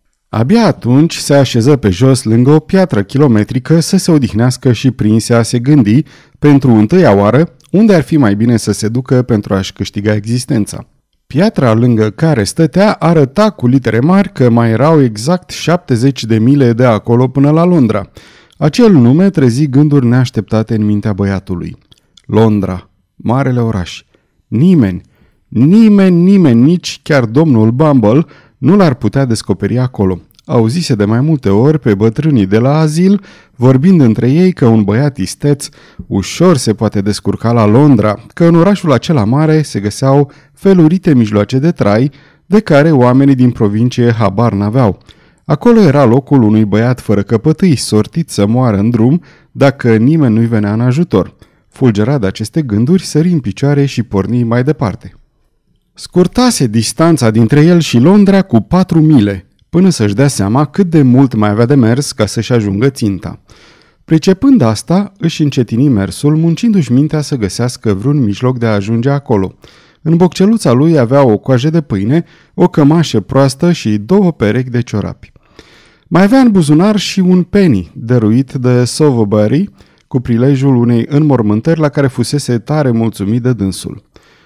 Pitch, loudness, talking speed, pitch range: 130 Hz, -10 LUFS, 160 wpm, 110-155 Hz